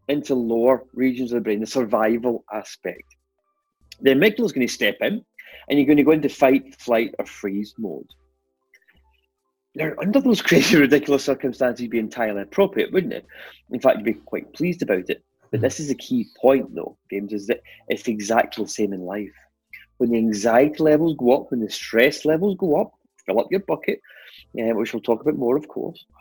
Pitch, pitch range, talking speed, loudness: 125 Hz, 110-145 Hz, 195 wpm, -21 LUFS